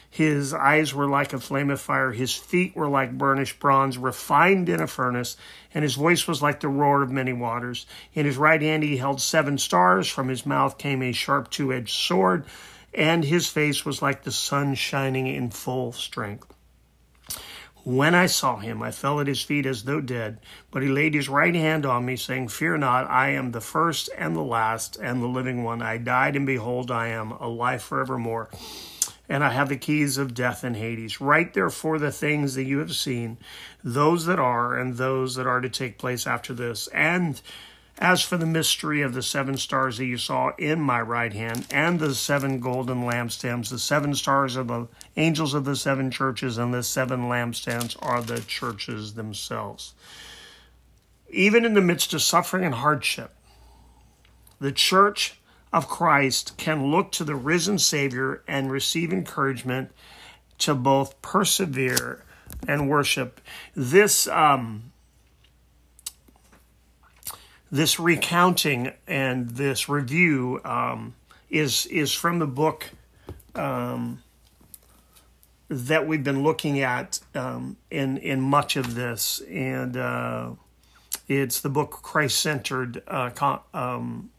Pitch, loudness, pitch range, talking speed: 135 Hz, -24 LUFS, 120-150 Hz, 160 wpm